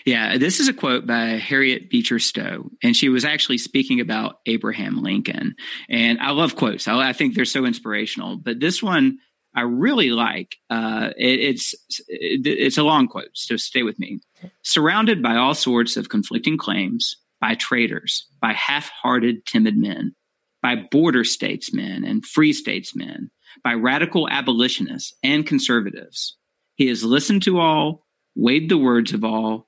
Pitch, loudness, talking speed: 155 Hz, -20 LUFS, 160 wpm